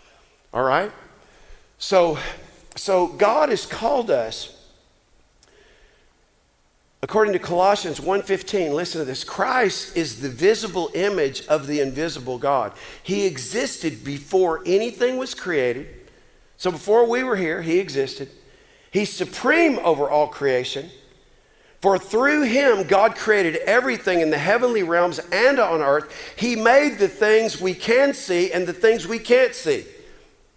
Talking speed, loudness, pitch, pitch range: 135 wpm, -21 LUFS, 195 Hz, 165-245 Hz